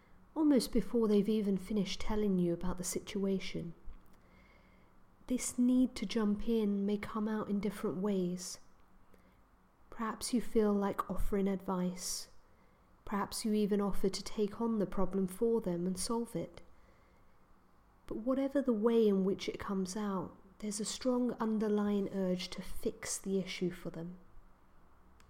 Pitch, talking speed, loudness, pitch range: 200 Hz, 145 wpm, -35 LUFS, 185-220 Hz